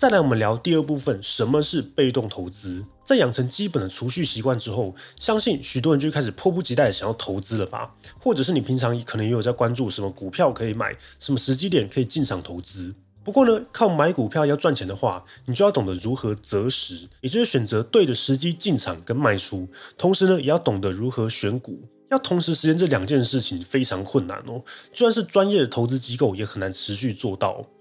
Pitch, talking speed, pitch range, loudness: 130 Hz, 335 characters per minute, 105-150 Hz, -22 LUFS